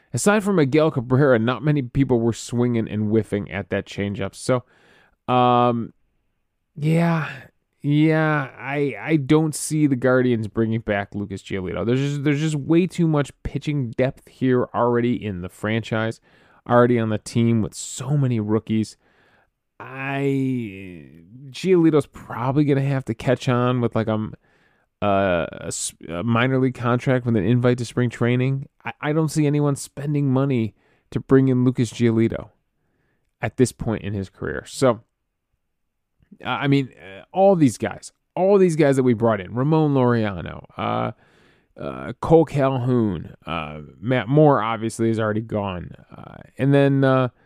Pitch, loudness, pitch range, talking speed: 125 Hz, -21 LUFS, 110-140 Hz, 150 wpm